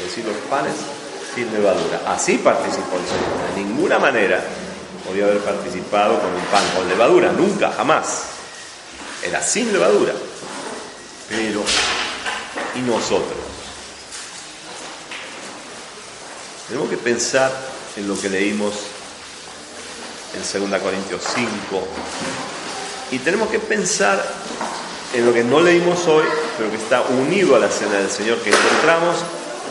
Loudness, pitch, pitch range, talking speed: -19 LUFS, 105 Hz, 100-130 Hz, 125 wpm